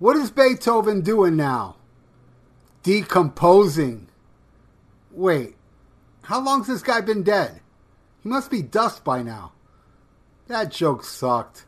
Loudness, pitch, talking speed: -21 LUFS, 190 Hz, 120 wpm